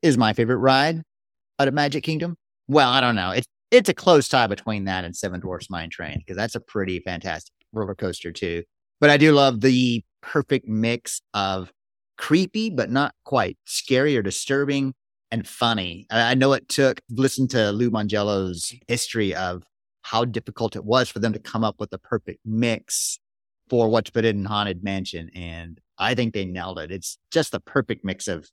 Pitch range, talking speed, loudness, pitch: 95-130 Hz, 190 wpm, -22 LUFS, 115 Hz